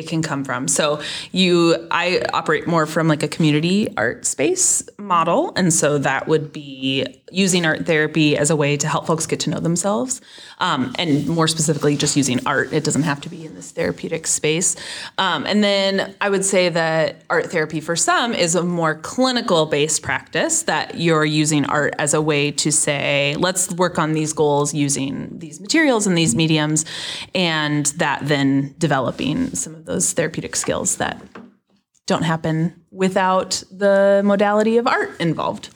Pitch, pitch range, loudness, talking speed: 160 Hz, 150-185 Hz, -18 LUFS, 175 wpm